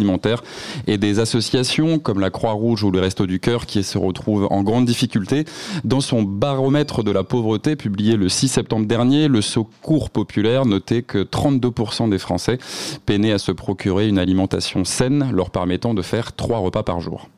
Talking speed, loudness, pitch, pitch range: 175 wpm, -19 LUFS, 110 Hz, 100-125 Hz